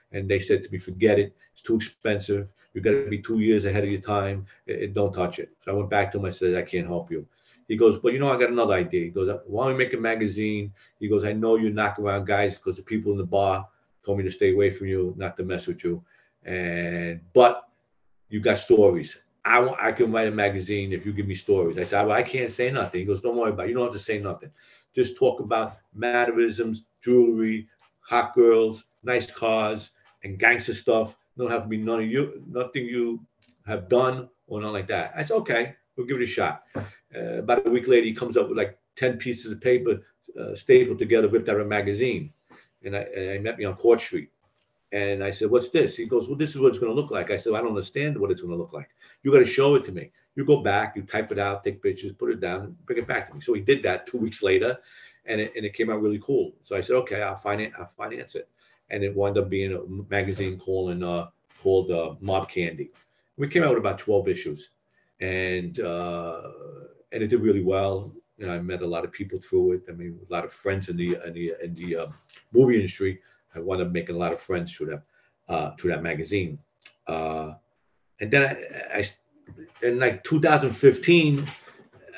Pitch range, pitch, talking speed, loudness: 95-125 Hz, 105 Hz, 245 wpm, -25 LUFS